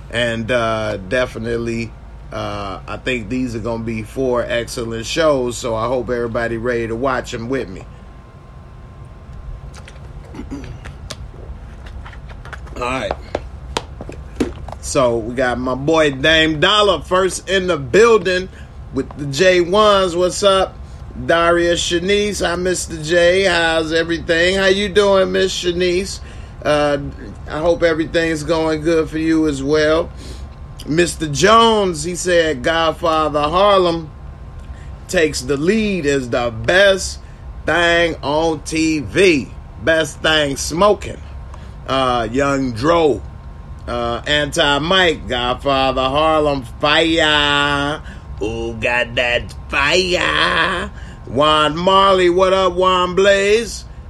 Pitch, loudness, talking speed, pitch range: 150 Hz, -16 LUFS, 110 wpm, 120-175 Hz